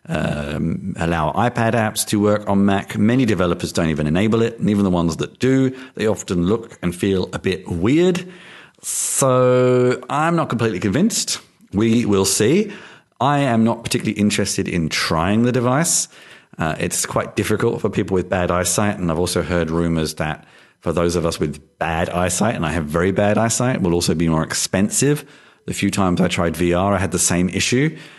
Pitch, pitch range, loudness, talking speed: 100 Hz, 90-120 Hz, -19 LUFS, 190 wpm